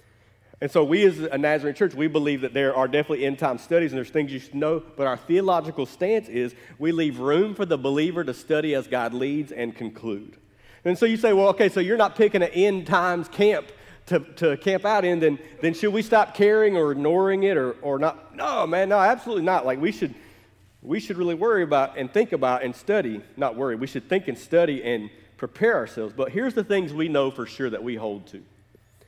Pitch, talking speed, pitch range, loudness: 155 Hz, 230 wpm, 130-190 Hz, -23 LUFS